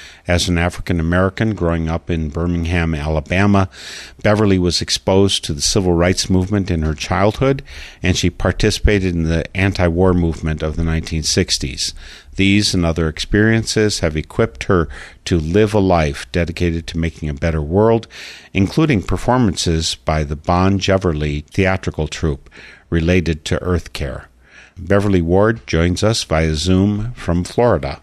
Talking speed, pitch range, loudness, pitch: 145 wpm, 80-100 Hz, -17 LUFS, 90 Hz